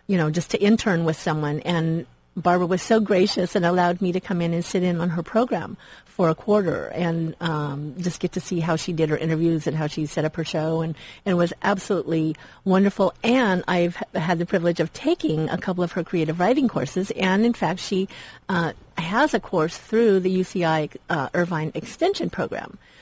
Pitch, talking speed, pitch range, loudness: 175 Hz, 210 wpm, 160-190 Hz, -23 LUFS